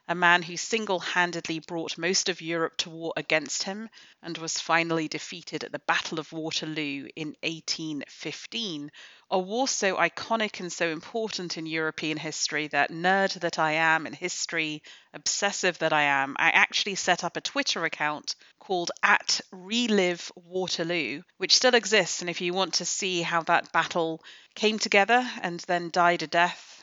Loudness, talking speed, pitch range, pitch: -26 LUFS, 165 wpm, 160-190 Hz, 170 Hz